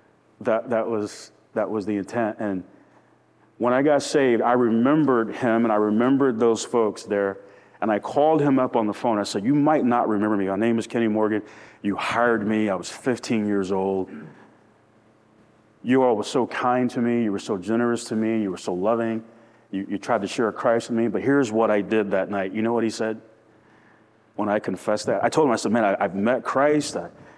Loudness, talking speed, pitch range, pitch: -23 LUFS, 225 wpm, 105-120 Hz, 110 Hz